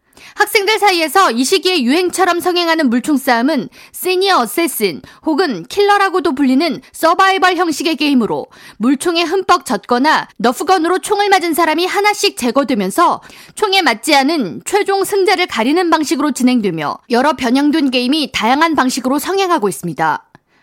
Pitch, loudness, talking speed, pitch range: 330 Hz, -14 LUFS, 360 characters per minute, 265-370 Hz